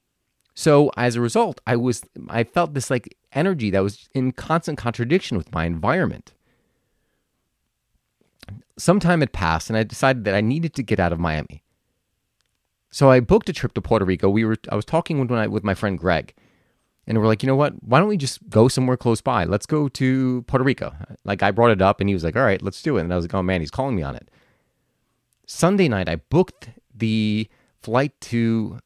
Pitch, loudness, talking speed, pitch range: 115 Hz, -21 LUFS, 215 wpm, 100-135 Hz